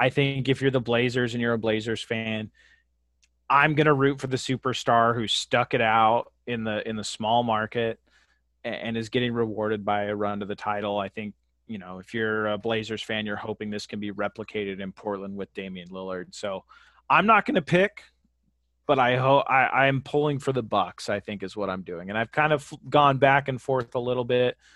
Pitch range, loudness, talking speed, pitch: 105-130 Hz, -25 LUFS, 215 wpm, 110 Hz